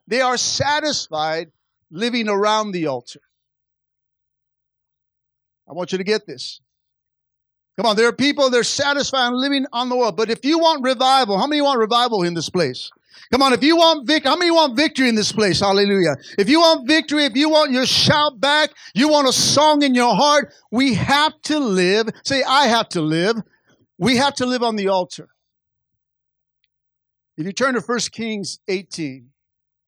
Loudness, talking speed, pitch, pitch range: -17 LUFS, 185 wpm, 240 Hz, 195-280 Hz